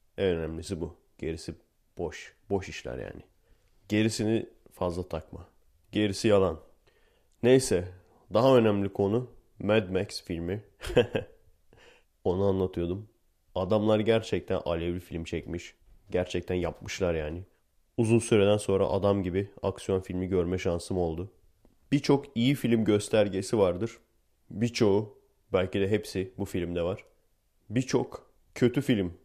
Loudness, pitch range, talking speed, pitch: -29 LUFS, 90-110 Hz, 115 wpm, 95 Hz